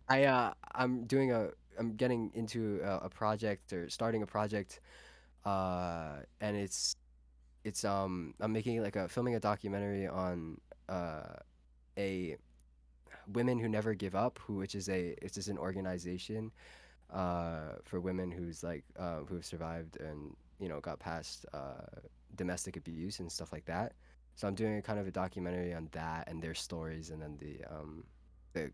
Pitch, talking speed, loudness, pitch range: 90 Hz, 170 wpm, -38 LUFS, 80-105 Hz